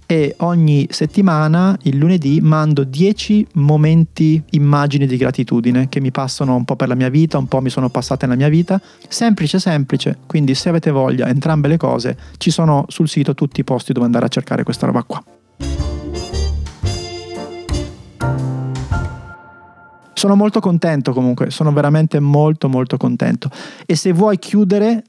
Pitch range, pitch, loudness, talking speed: 130-165 Hz, 145 Hz, -15 LUFS, 155 wpm